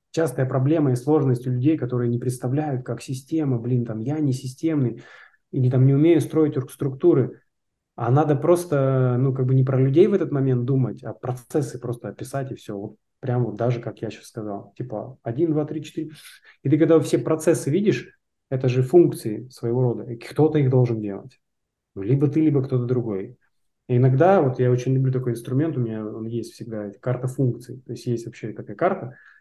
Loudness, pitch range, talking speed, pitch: -22 LUFS, 120-150 Hz, 195 wpm, 130 Hz